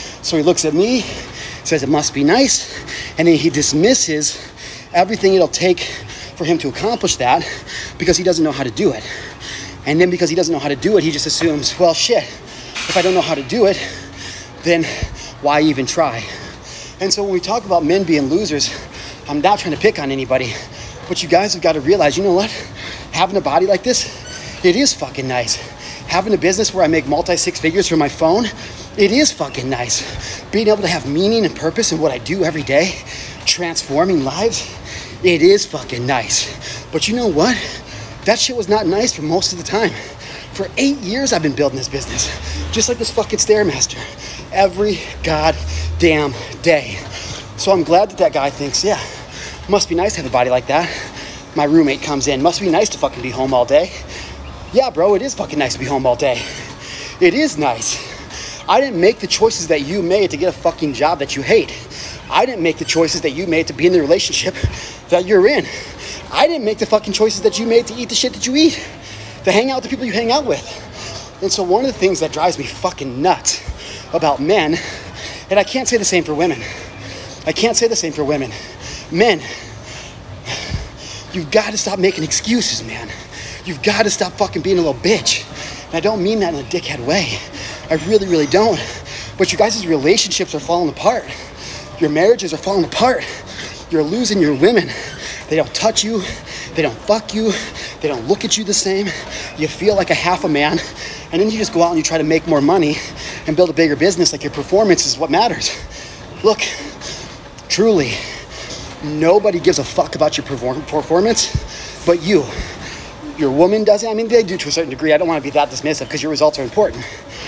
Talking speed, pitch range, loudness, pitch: 210 wpm, 135-200 Hz, -16 LUFS, 160 Hz